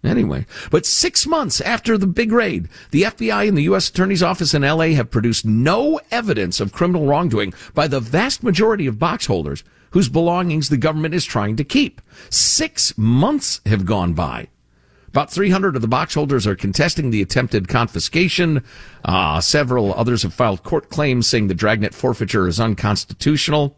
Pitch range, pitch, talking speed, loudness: 105-175 Hz, 140 Hz, 170 wpm, -17 LUFS